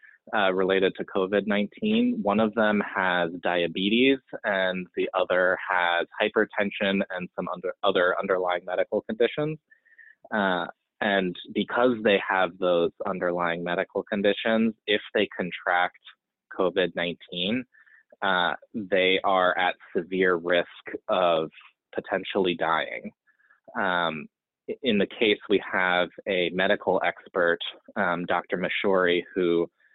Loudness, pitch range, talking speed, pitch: -25 LUFS, 90-105 Hz, 115 wpm, 95 Hz